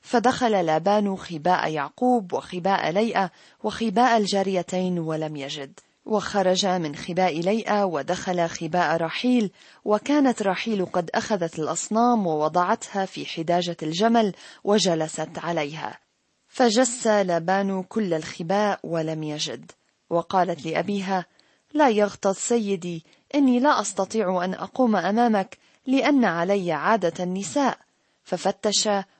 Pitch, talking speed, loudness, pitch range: 195 Hz, 105 wpm, -23 LUFS, 170-220 Hz